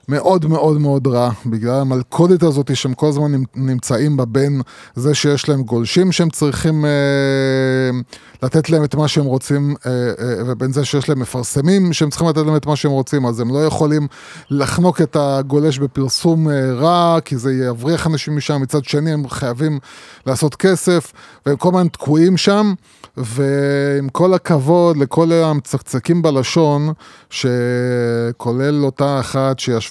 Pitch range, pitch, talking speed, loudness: 130-155 Hz, 145 Hz, 155 wpm, -16 LUFS